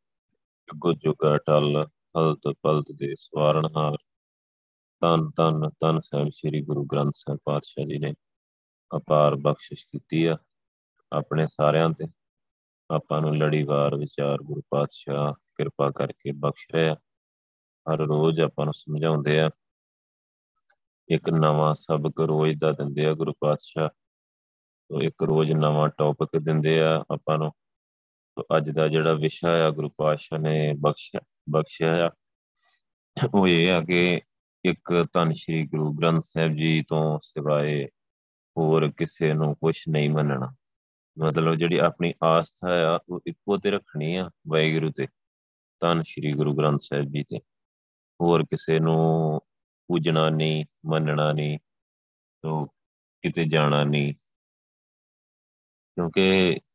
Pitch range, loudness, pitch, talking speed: 75-80 Hz, -24 LUFS, 75 Hz, 125 wpm